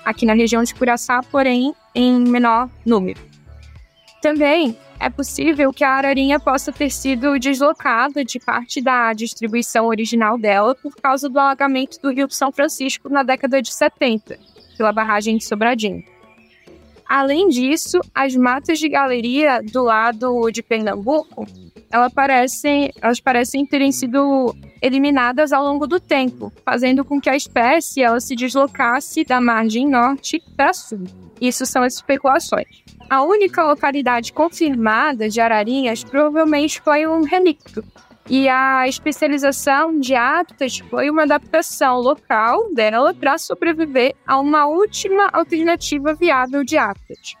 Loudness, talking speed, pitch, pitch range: -17 LUFS, 135 wpm, 270 Hz, 240-295 Hz